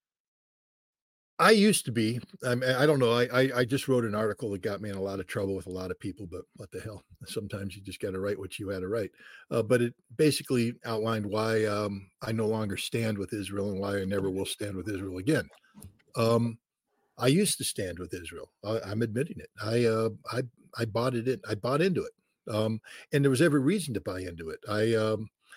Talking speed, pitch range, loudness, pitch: 230 wpm, 100-125 Hz, -29 LUFS, 110 Hz